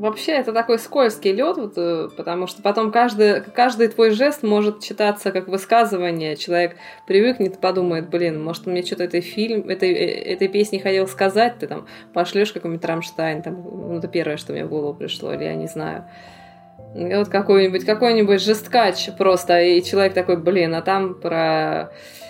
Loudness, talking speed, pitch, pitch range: -20 LUFS, 165 wpm, 190 Hz, 170-215 Hz